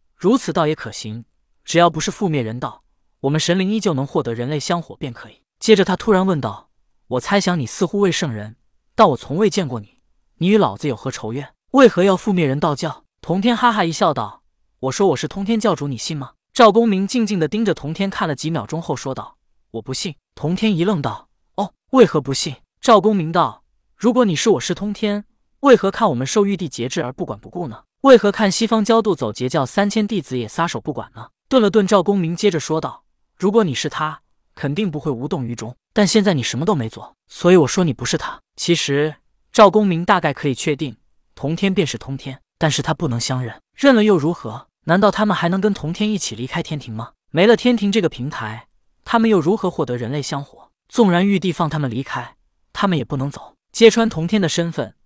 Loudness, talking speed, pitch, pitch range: -18 LUFS, 320 characters per minute, 165 Hz, 135-205 Hz